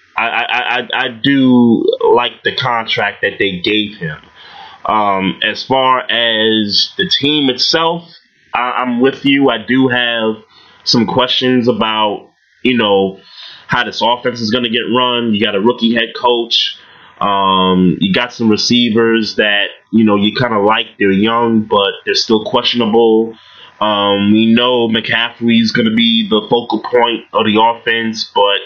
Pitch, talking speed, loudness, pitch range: 115 Hz, 165 wpm, -12 LUFS, 110-130 Hz